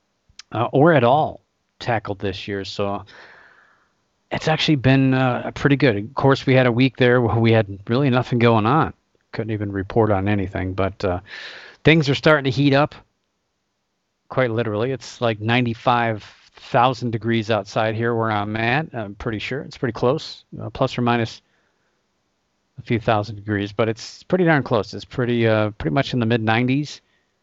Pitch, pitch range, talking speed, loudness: 115 Hz, 105-130 Hz, 175 wpm, -20 LUFS